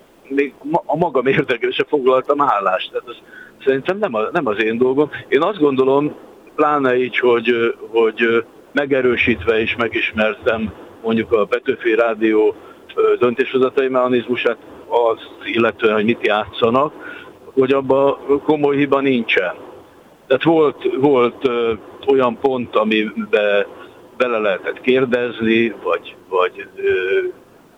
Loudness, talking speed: -17 LUFS, 110 wpm